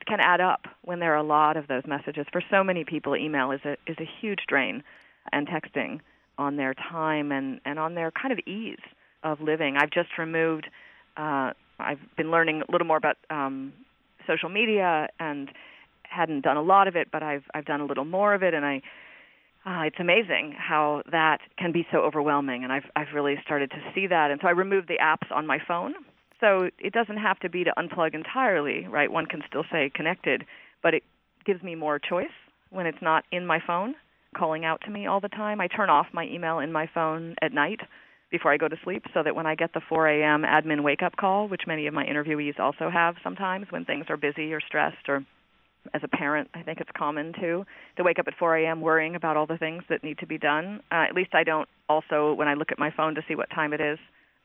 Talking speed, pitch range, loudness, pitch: 230 wpm, 150-175 Hz, -26 LUFS, 160 Hz